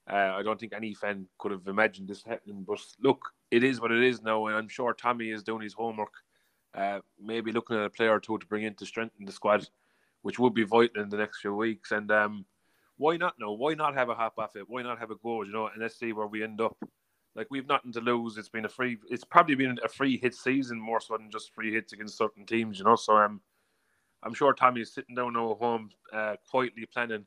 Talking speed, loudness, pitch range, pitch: 260 wpm, -30 LUFS, 105-120 Hz, 110 Hz